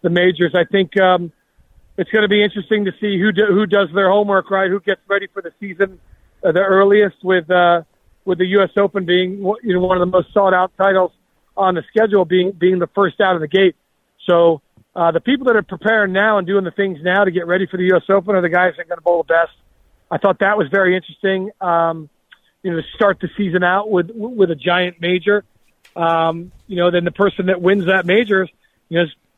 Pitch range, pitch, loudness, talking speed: 175-200 Hz, 185 Hz, -16 LUFS, 240 wpm